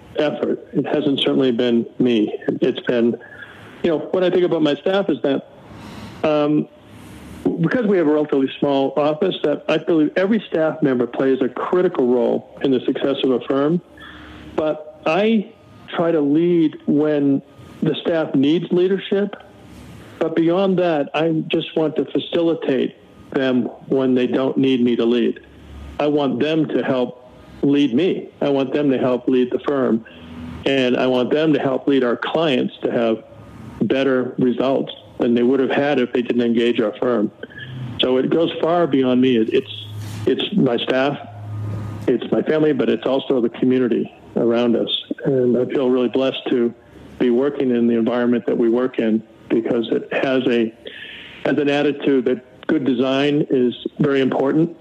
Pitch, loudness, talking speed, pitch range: 130 Hz, -19 LUFS, 170 wpm, 120-150 Hz